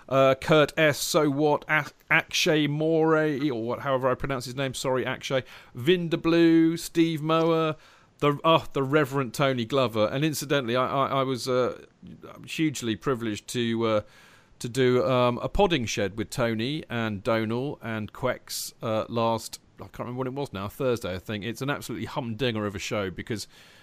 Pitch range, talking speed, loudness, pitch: 115-150 Hz, 175 wpm, -26 LUFS, 130 Hz